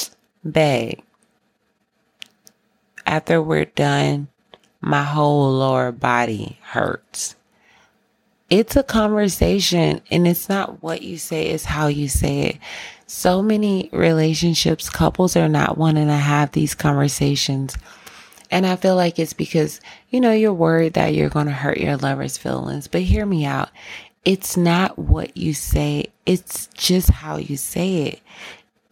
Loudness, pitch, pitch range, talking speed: -19 LUFS, 155 Hz, 140-185 Hz, 140 wpm